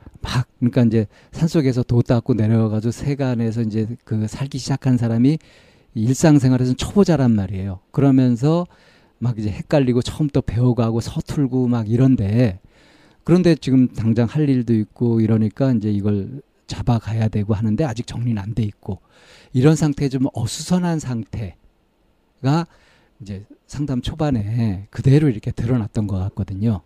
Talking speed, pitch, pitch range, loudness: 335 characters per minute, 120 Hz, 110-135 Hz, -19 LUFS